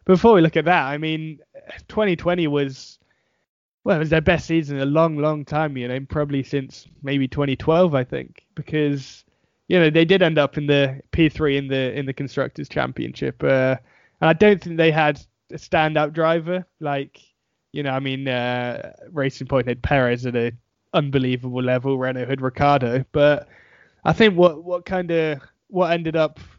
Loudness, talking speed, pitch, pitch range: -20 LUFS, 185 wpm, 145 Hz, 135-165 Hz